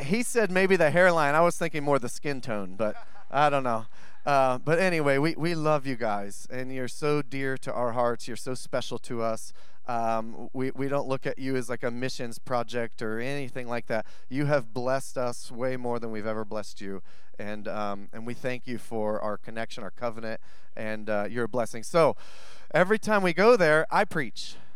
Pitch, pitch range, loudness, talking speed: 125 Hz, 115-140 Hz, -28 LUFS, 210 wpm